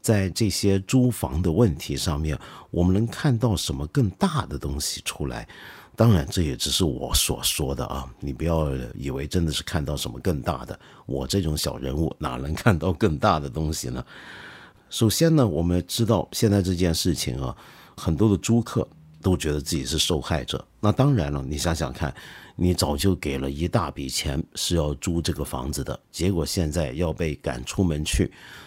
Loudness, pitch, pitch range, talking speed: -24 LUFS, 85 Hz, 75-100 Hz, 270 characters per minute